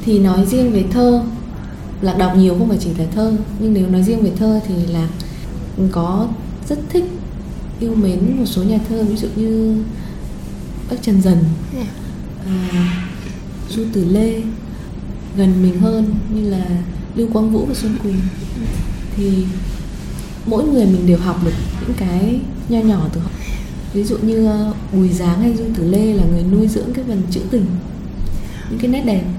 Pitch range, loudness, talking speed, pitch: 180-220 Hz, -17 LUFS, 175 wpm, 200 Hz